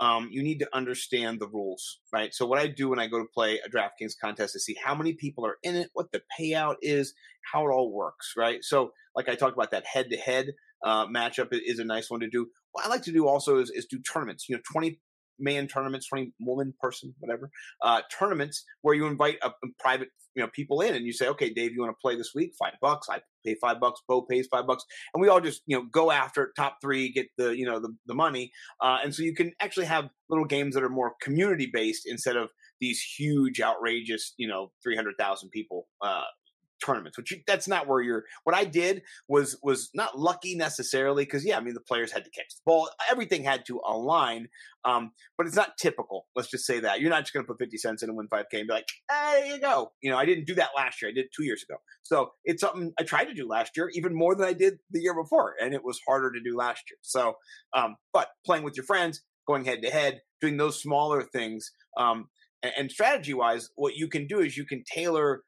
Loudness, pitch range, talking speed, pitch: -28 LUFS, 120-165 Hz, 250 wpm, 140 Hz